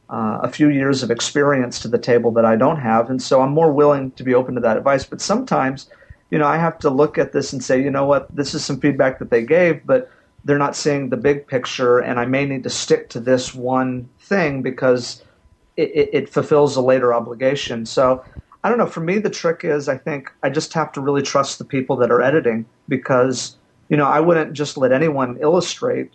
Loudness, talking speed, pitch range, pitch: -18 LUFS, 235 wpm, 130-150 Hz, 140 Hz